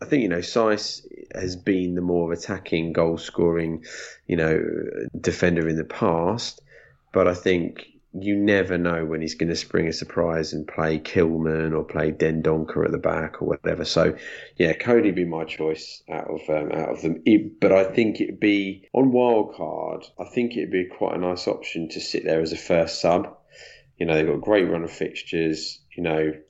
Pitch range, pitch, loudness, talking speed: 80-90 Hz, 85 Hz, -23 LUFS, 195 wpm